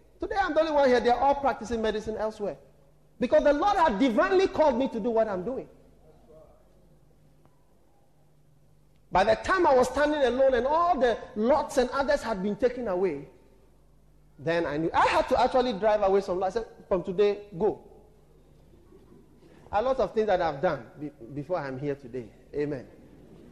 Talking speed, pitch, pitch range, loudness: 175 wpm, 230 Hz, 185-275 Hz, -26 LUFS